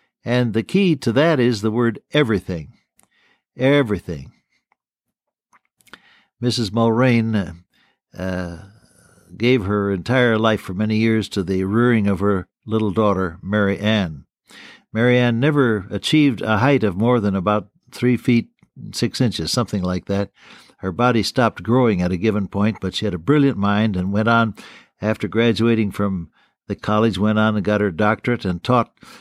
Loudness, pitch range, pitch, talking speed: -19 LUFS, 100-120 Hz, 110 Hz, 160 wpm